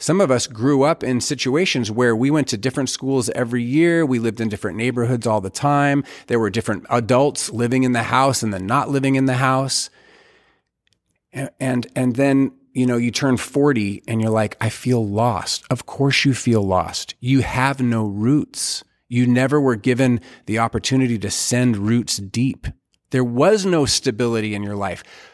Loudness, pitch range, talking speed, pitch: -19 LUFS, 115-135 Hz, 185 wpm, 125 Hz